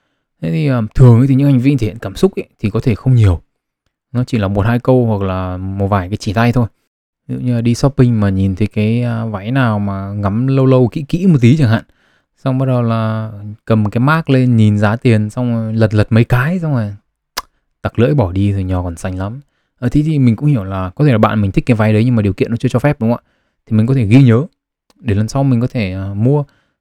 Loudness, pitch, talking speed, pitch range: -14 LUFS, 115 Hz, 265 wpm, 105-130 Hz